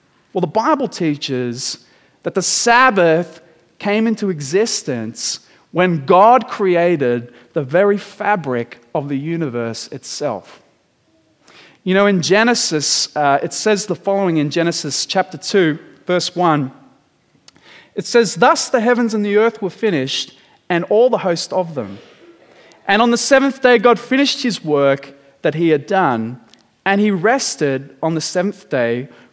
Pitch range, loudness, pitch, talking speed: 145-210 Hz, -16 LUFS, 180 Hz, 145 wpm